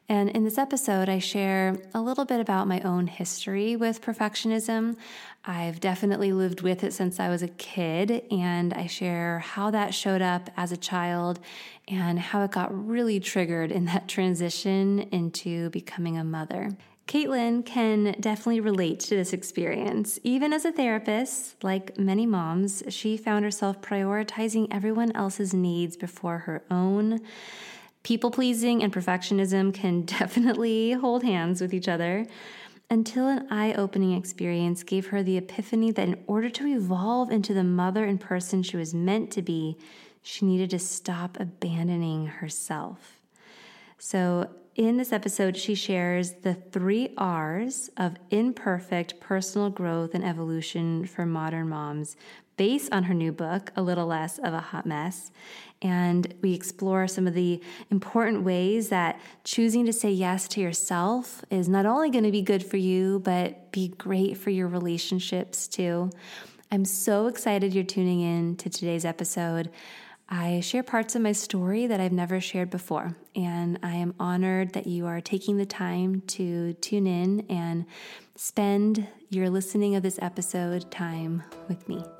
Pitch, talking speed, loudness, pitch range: 190 Hz, 160 wpm, -27 LUFS, 175-210 Hz